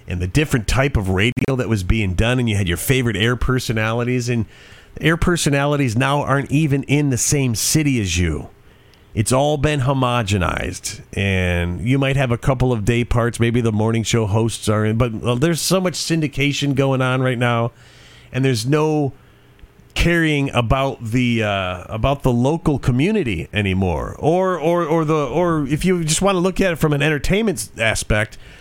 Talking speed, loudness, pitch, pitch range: 185 wpm, -18 LUFS, 125 Hz, 110-145 Hz